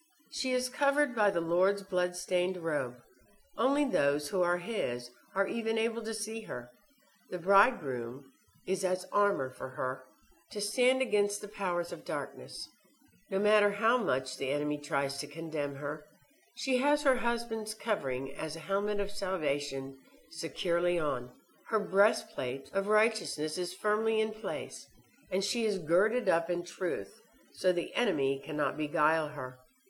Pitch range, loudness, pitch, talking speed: 150-215 Hz, -32 LUFS, 185 Hz, 155 wpm